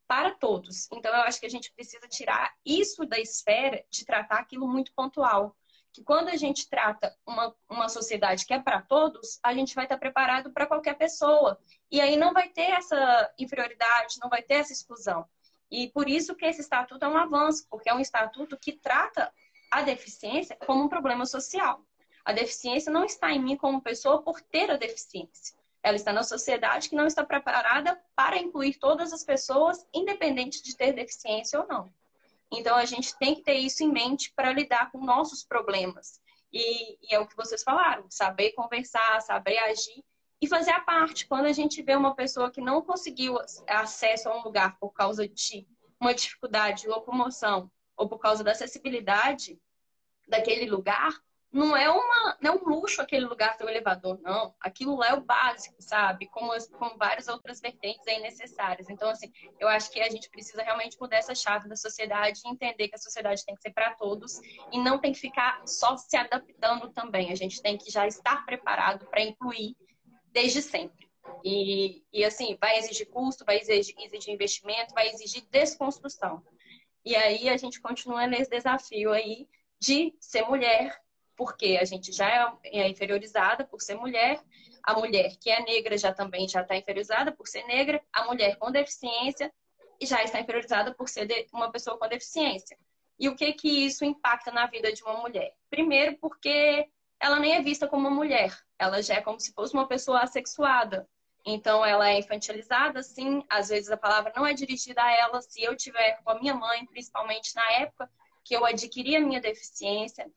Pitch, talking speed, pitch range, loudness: 245 Hz, 190 wpm, 220-285 Hz, -27 LUFS